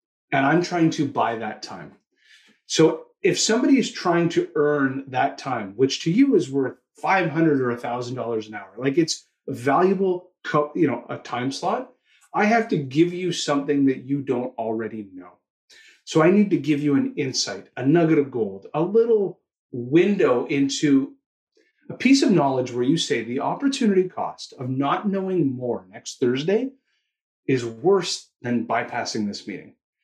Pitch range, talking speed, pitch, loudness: 125-185 Hz, 170 wpm, 150 Hz, -22 LUFS